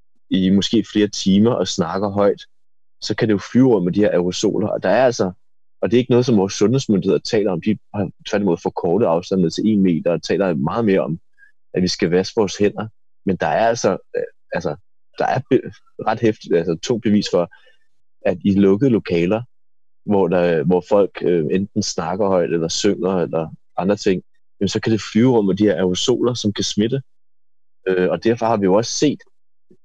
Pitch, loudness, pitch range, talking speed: 100 Hz, -18 LUFS, 95-115 Hz, 205 wpm